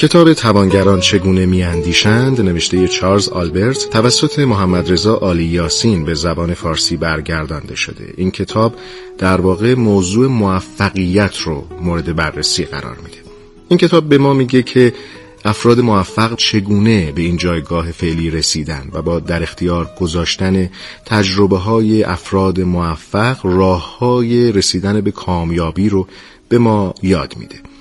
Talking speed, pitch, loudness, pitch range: 135 wpm, 95 Hz, -14 LUFS, 85-110 Hz